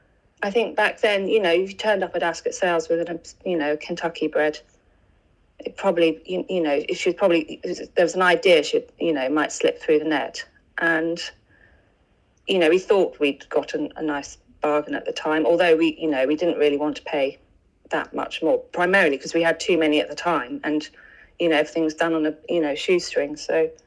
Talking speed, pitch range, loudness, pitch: 220 wpm, 150-185 Hz, -22 LUFS, 165 Hz